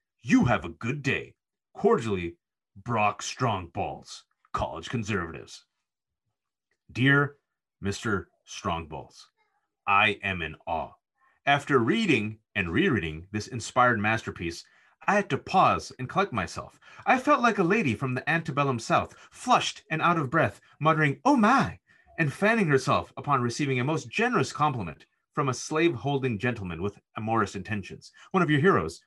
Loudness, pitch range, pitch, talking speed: -26 LUFS, 105-160 Hz, 130 Hz, 140 wpm